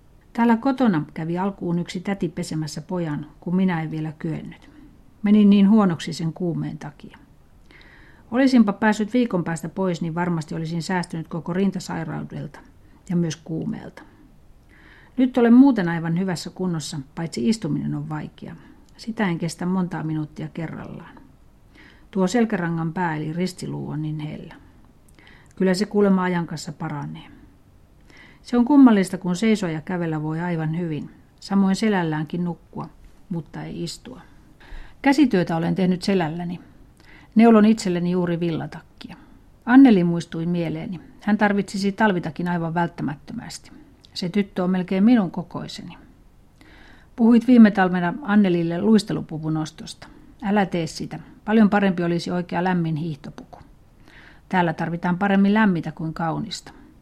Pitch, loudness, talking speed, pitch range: 180 Hz, -21 LUFS, 130 wpm, 165-205 Hz